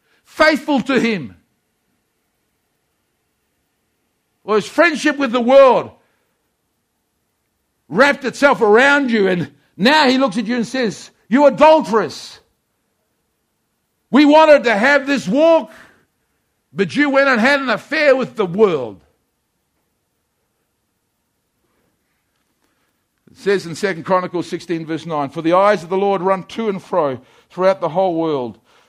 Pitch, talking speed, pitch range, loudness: 220 Hz, 130 wpm, 185-275 Hz, -15 LUFS